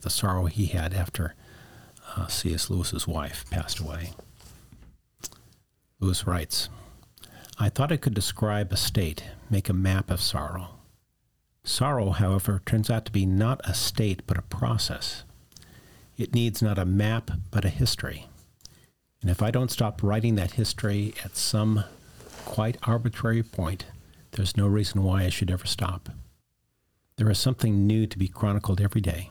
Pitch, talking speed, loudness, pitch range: 100 Hz, 155 wpm, -27 LUFS, 95-110 Hz